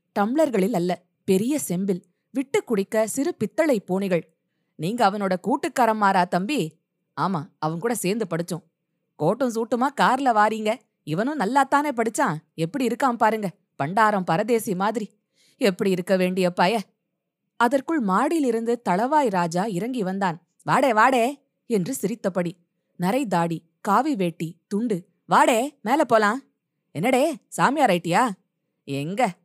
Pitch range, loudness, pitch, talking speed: 175-240 Hz, -23 LUFS, 200 Hz, 120 wpm